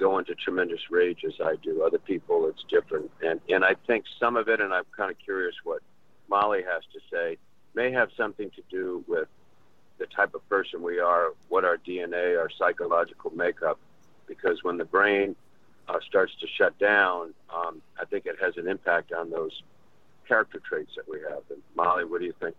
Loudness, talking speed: -27 LUFS, 200 wpm